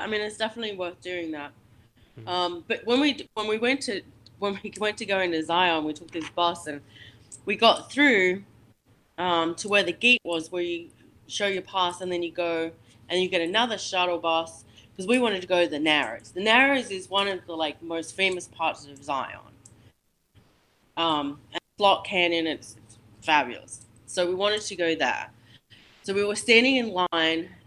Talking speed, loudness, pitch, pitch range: 195 wpm, -25 LUFS, 175 Hz, 150-200 Hz